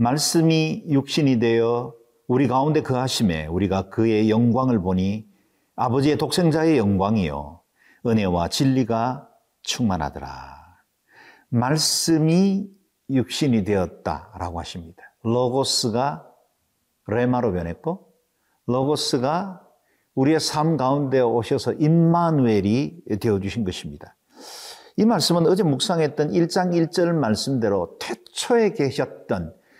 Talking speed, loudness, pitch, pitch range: 250 characters per minute, -21 LUFS, 130 Hz, 110-160 Hz